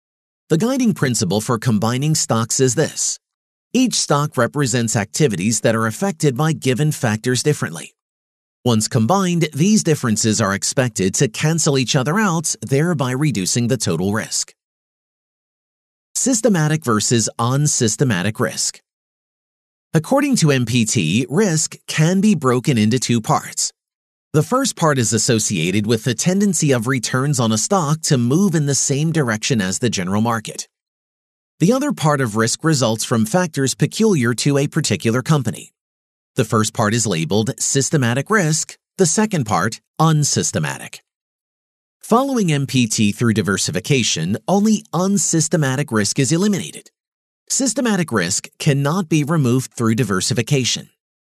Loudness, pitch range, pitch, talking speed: -17 LUFS, 115-160 Hz, 140 Hz, 130 wpm